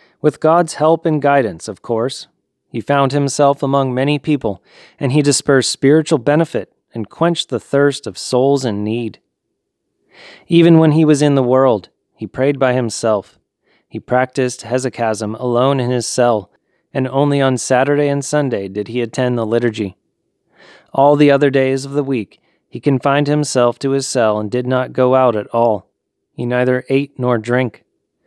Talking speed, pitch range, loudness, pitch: 170 wpm, 120-145 Hz, -15 LUFS, 130 Hz